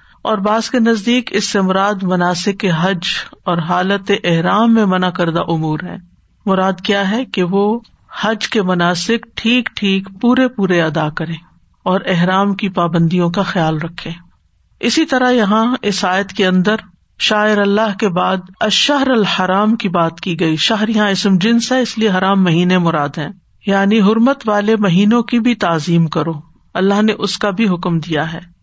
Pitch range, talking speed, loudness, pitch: 175-215 Hz, 170 wpm, -15 LUFS, 195 Hz